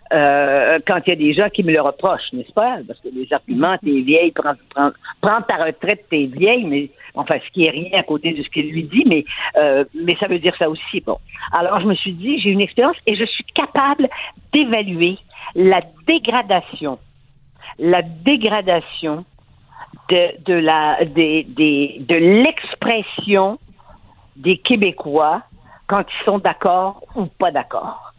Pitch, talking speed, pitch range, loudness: 175 Hz, 175 wpm, 150-205 Hz, -17 LUFS